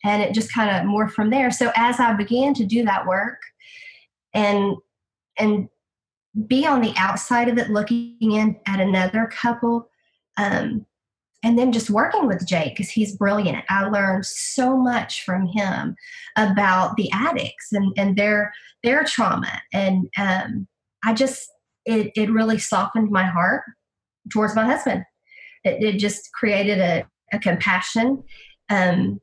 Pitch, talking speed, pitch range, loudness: 215 Hz, 150 wpm, 195-235 Hz, -21 LUFS